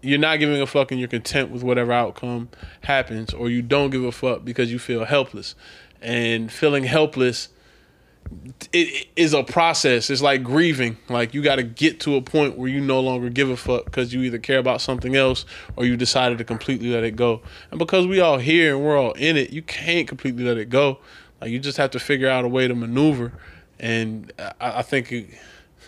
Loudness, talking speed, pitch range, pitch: -21 LUFS, 220 wpm, 120-140 Hz, 130 Hz